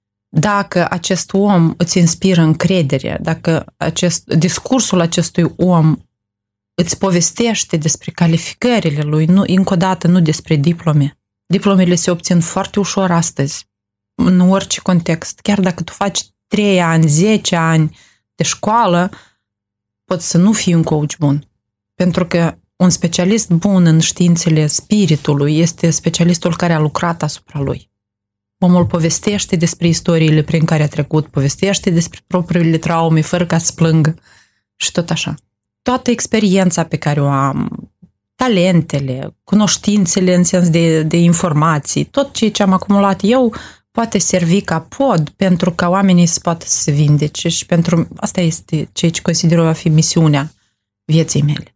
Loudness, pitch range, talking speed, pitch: -14 LUFS, 155-185 Hz, 145 wpm, 170 Hz